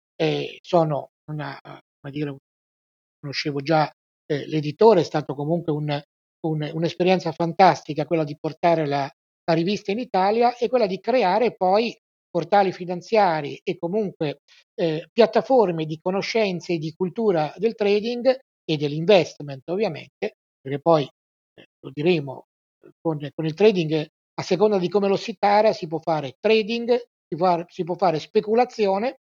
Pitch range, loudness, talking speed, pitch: 155-205 Hz, -22 LUFS, 145 wpm, 175 Hz